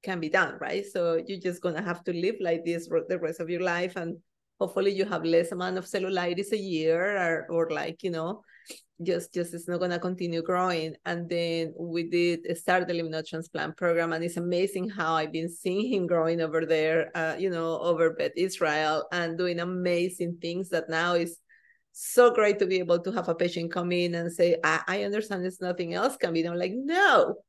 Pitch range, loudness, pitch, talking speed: 165-185 Hz, -28 LUFS, 175 Hz, 220 wpm